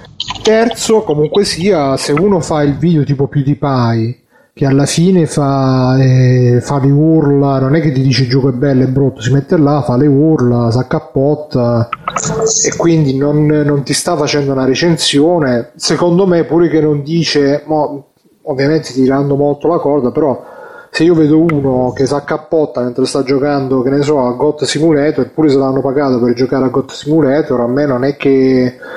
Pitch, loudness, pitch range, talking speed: 145 Hz, -12 LUFS, 135-155 Hz, 180 wpm